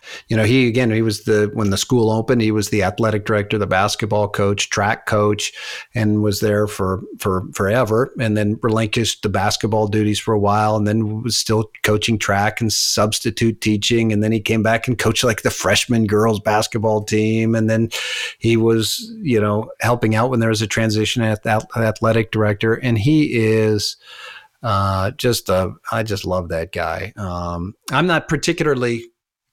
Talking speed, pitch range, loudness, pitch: 180 wpm, 105-115 Hz, -18 LUFS, 110 Hz